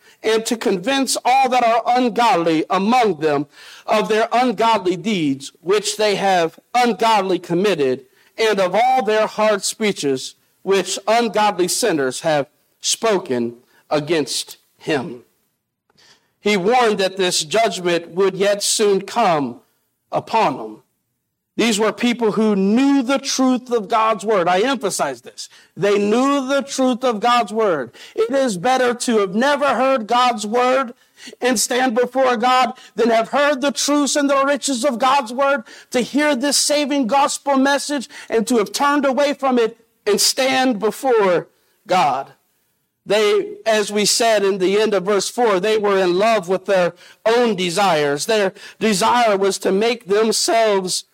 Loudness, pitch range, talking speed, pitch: -17 LUFS, 195-260 Hz, 150 wpm, 225 Hz